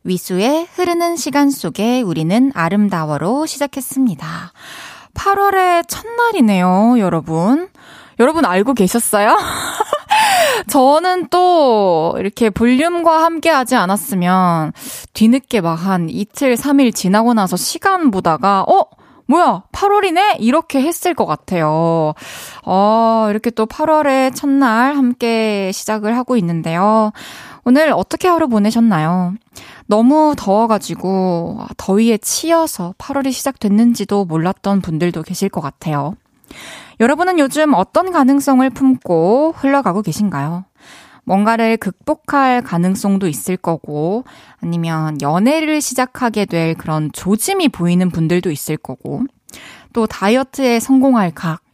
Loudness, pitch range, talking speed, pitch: -15 LUFS, 185-285 Hz, 270 characters per minute, 225 Hz